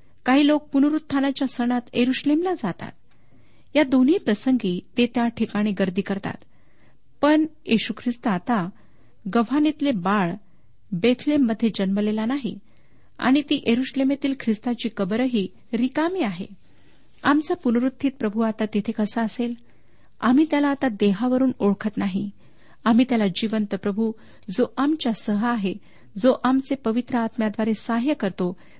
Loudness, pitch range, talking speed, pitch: -23 LUFS, 205-265 Hz, 120 wpm, 235 Hz